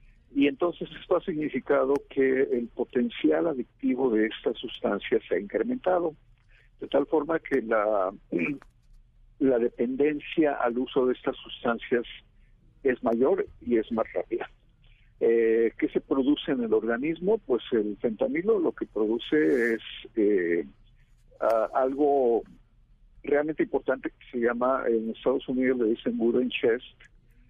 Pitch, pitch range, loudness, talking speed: 135 Hz, 120-175 Hz, -27 LUFS, 135 wpm